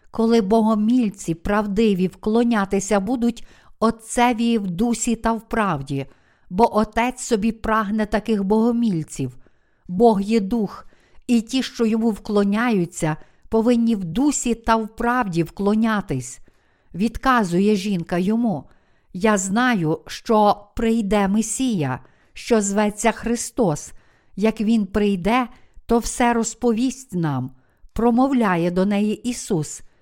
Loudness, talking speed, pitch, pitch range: -21 LUFS, 110 wpm, 220 Hz, 195-235 Hz